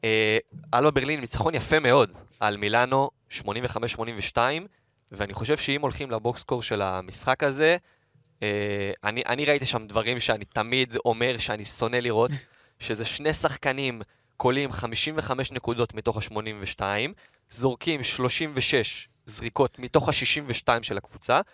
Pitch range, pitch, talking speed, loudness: 110-140 Hz, 120 Hz, 125 wpm, -26 LUFS